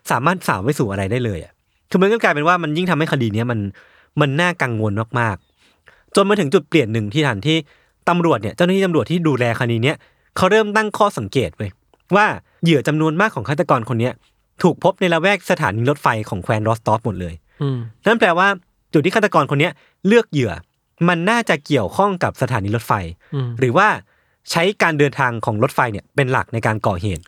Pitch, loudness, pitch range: 145 Hz, -18 LUFS, 115-175 Hz